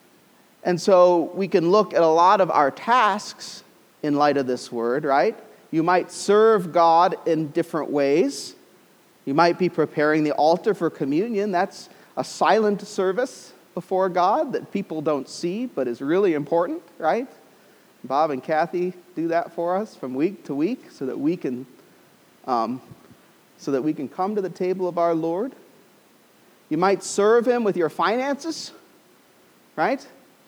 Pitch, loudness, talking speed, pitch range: 180 Hz, -22 LUFS, 160 wpm, 160-205 Hz